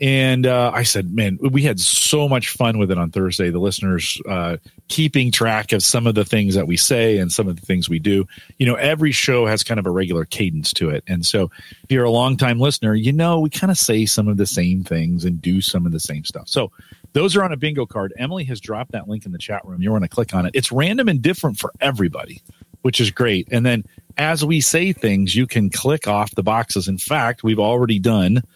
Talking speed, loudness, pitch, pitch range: 250 wpm, -18 LUFS, 110 Hz, 95-130 Hz